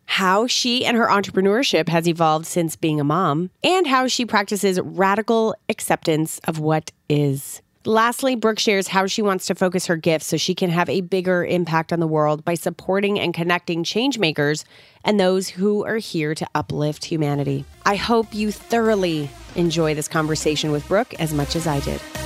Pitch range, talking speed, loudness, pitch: 155-205 Hz, 180 wpm, -20 LUFS, 175 Hz